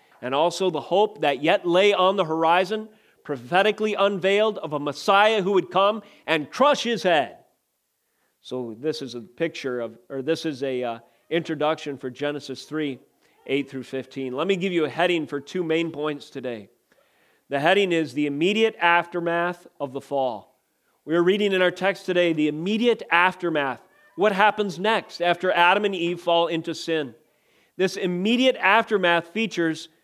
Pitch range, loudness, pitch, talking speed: 145-195 Hz, -23 LUFS, 170 Hz, 170 wpm